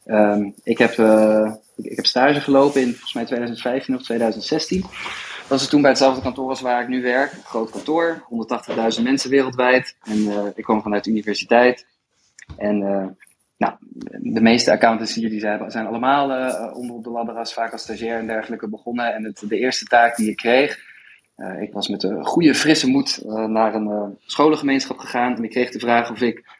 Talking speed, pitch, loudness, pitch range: 210 wpm, 120 Hz, -19 LUFS, 110-130 Hz